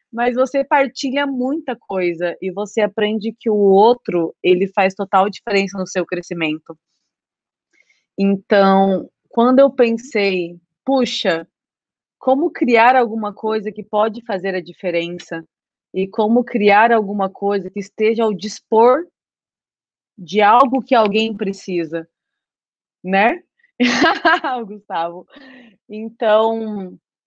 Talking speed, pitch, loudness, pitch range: 110 wpm, 210 Hz, -17 LUFS, 190-240 Hz